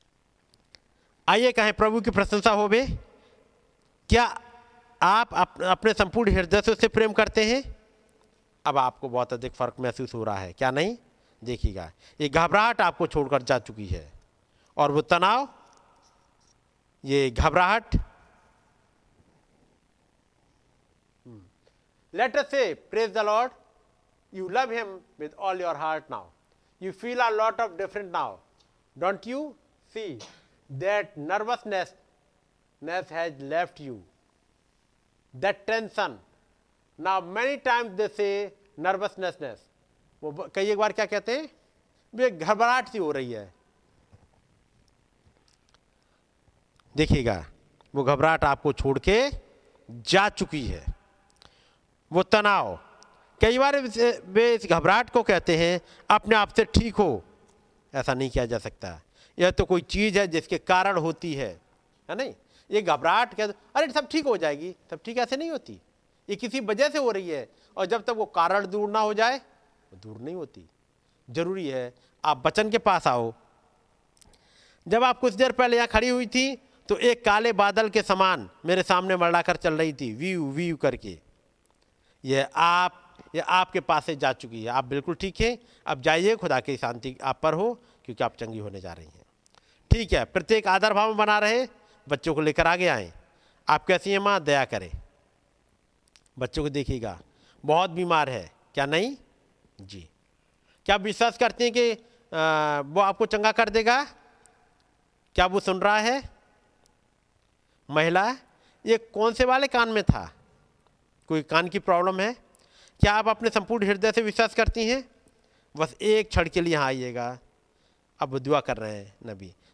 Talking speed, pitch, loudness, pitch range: 150 wpm, 190 Hz, -25 LUFS, 145-225 Hz